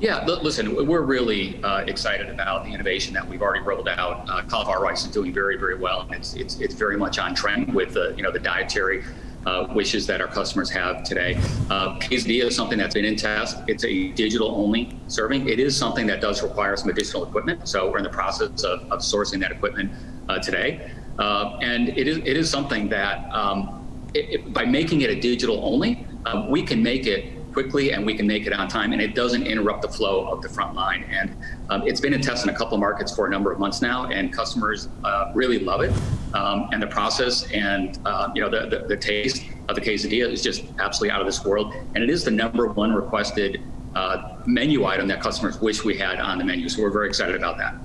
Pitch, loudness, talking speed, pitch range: 110 Hz, -23 LUFS, 235 wpm, 105-125 Hz